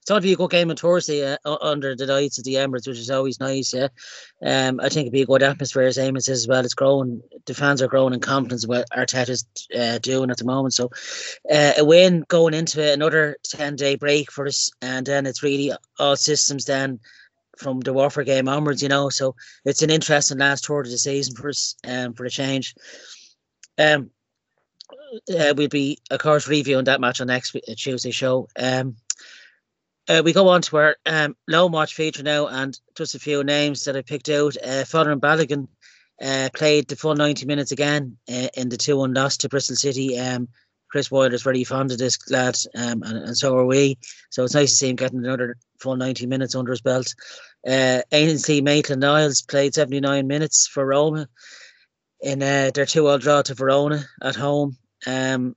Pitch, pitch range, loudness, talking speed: 135 Hz, 130-145 Hz, -20 LUFS, 210 wpm